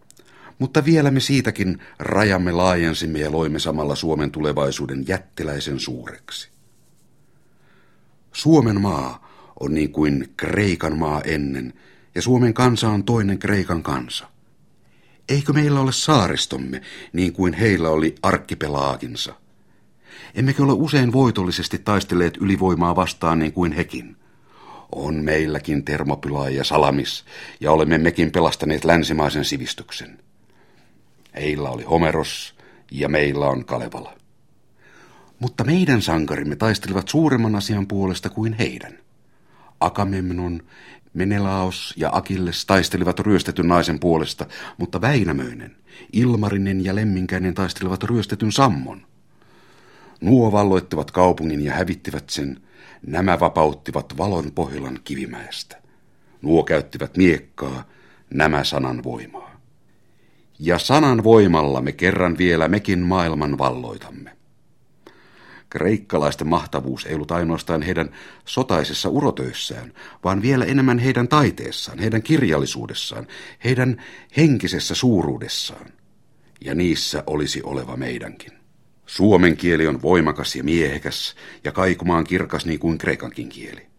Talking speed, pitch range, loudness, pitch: 110 wpm, 75-105 Hz, -20 LUFS, 90 Hz